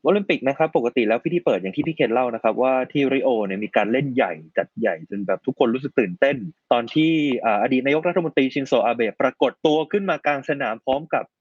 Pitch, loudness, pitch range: 140 Hz, -21 LUFS, 120-155 Hz